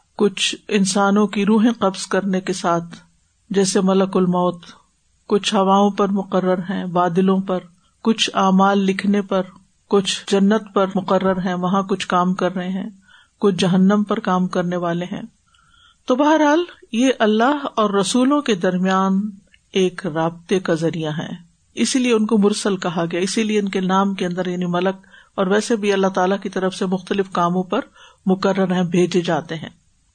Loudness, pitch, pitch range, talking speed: -19 LUFS, 195 Hz, 185-210 Hz, 170 wpm